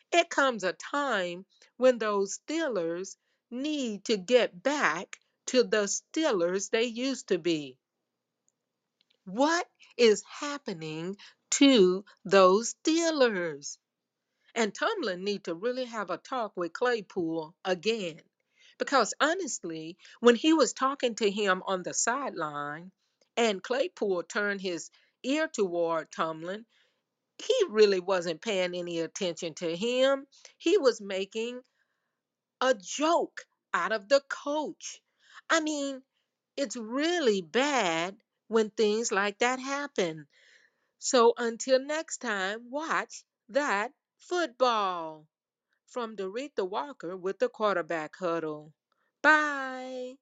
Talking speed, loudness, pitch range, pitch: 115 wpm, -29 LUFS, 185-270 Hz, 225 Hz